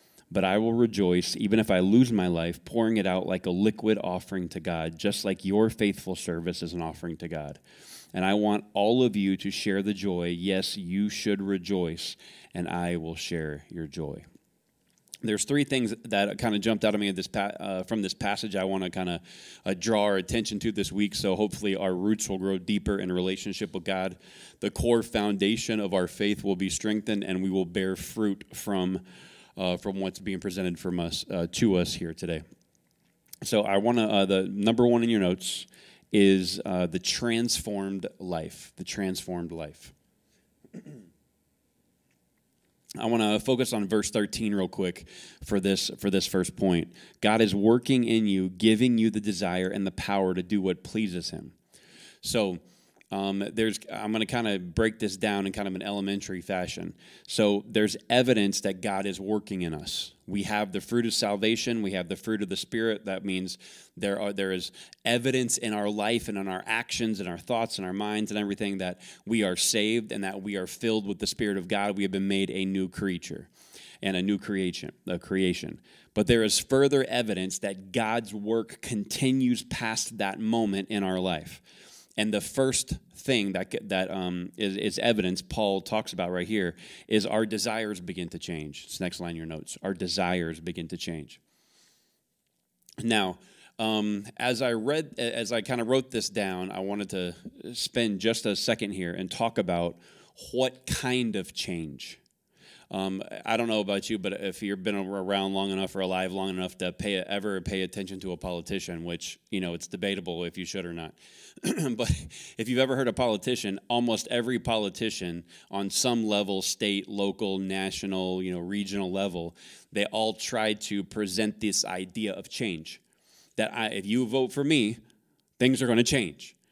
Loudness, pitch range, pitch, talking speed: -28 LUFS, 95-110 Hz, 100 Hz, 190 wpm